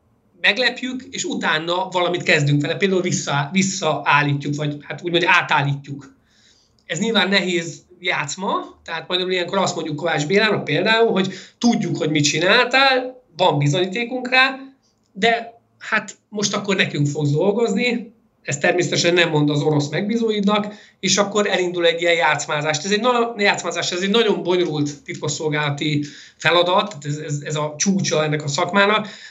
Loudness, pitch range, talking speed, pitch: -19 LUFS, 155-210 Hz, 145 wpm, 175 Hz